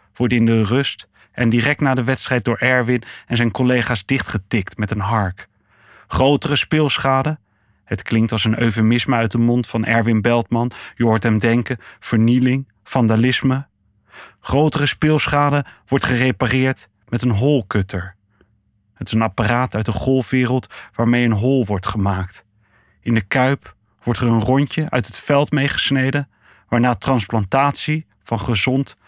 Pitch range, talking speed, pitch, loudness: 110-130 Hz, 145 wpm, 120 Hz, -18 LUFS